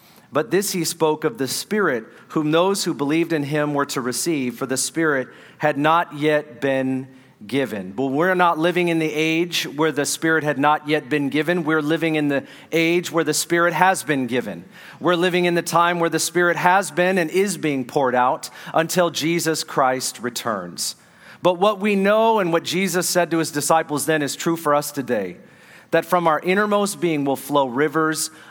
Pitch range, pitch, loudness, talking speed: 145-175 Hz, 160 Hz, -20 LUFS, 200 wpm